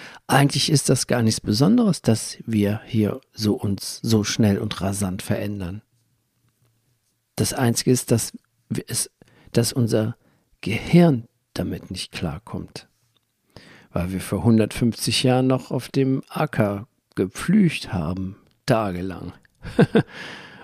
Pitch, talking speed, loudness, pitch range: 115 Hz, 115 wpm, -22 LUFS, 100-125 Hz